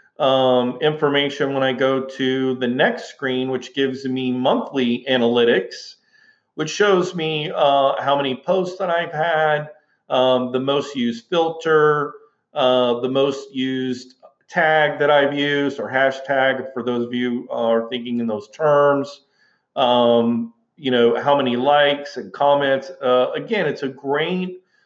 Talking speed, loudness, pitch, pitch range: 150 wpm, -19 LUFS, 135 Hz, 125-150 Hz